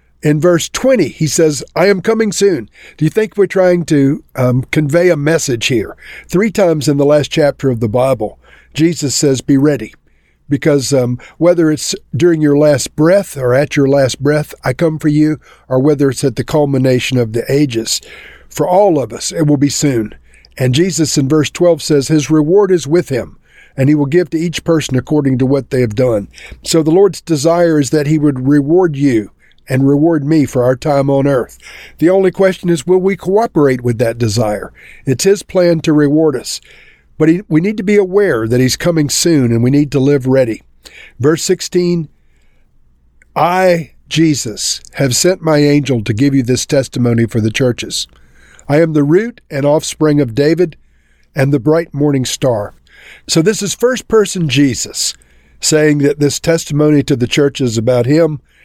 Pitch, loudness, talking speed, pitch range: 145 Hz, -13 LUFS, 190 wpm, 130-165 Hz